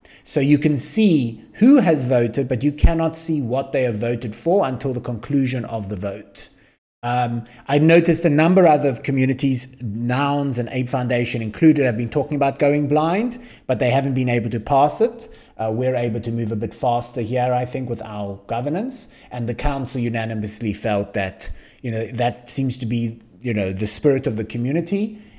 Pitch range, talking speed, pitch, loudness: 115-145 Hz, 195 wpm, 125 Hz, -20 LUFS